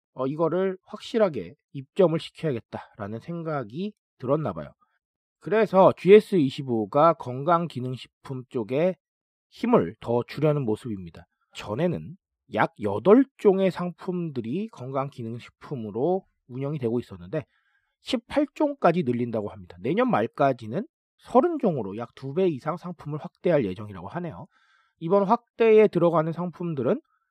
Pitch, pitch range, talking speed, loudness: 160 Hz, 125-195 Hz, 280 characters per minute, -25 LUFS